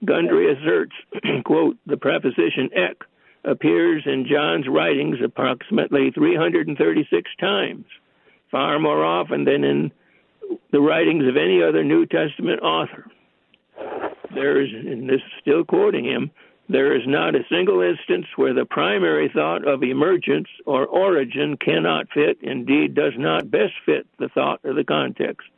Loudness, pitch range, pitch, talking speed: -20 LUFS, 325-405 Hz, 370 Hz, 140 wpm